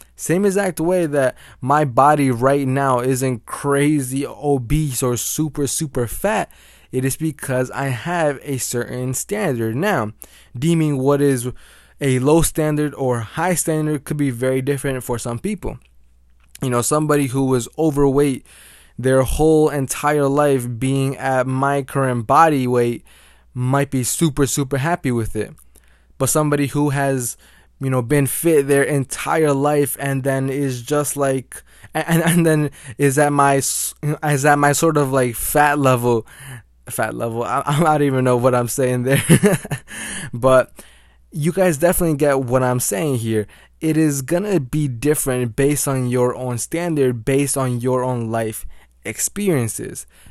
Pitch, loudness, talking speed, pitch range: 135 Hz, -18 LUFS, 155 wpm, 125-150 Hz